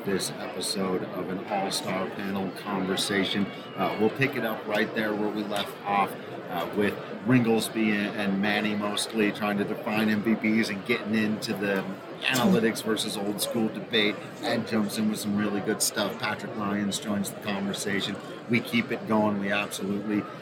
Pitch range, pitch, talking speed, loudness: 105-110 Hz, 105 Hz, 170 wpm, -27 LUFS